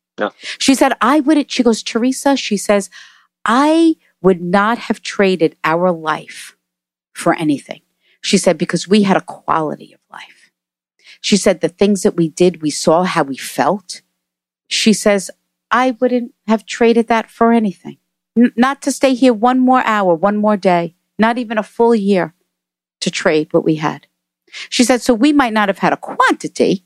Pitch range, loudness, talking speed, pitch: 165-240 Hz, -15 LUFS, 175 wpm, 205 Hz